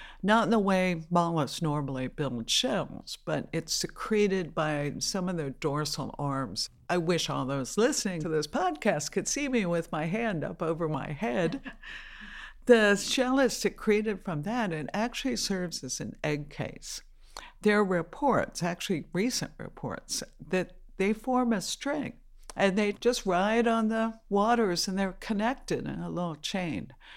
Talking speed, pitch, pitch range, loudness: 160 wpm, 190 Hz, 160-225 Hz, -29 LUFS